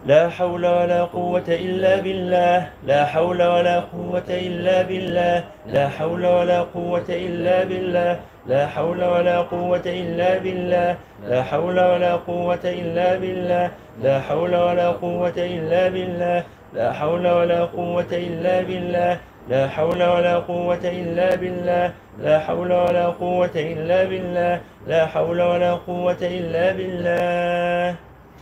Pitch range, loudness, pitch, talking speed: 175-180 Hz, -21 LUFS, 175 Hz, 125 wpm